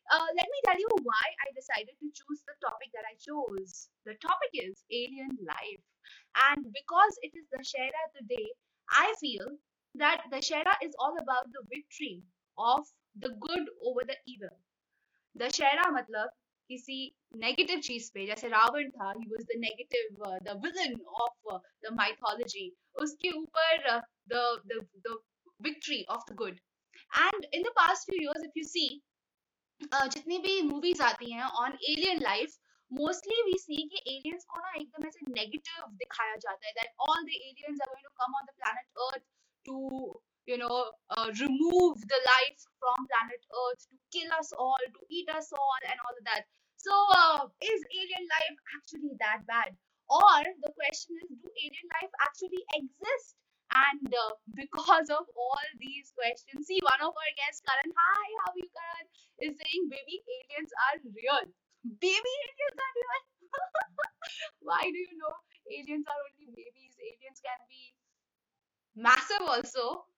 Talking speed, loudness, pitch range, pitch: 160 wpm, -31 LUFS, 250-340 Hz, 285 Hz